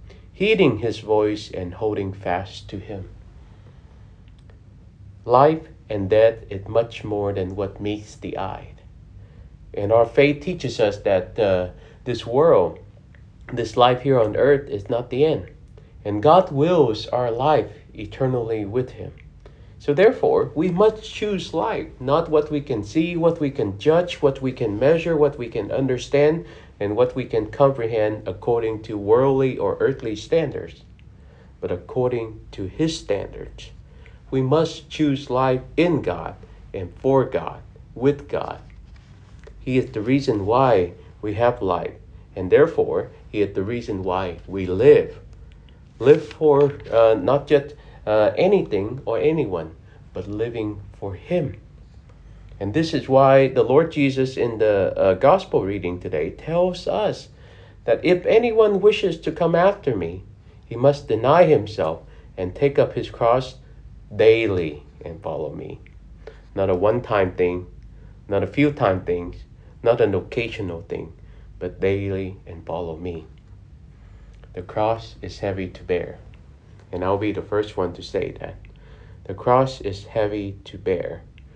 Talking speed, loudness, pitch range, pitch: 150 wpm, -21 LUFS, 100-145 Hz, 115 Hz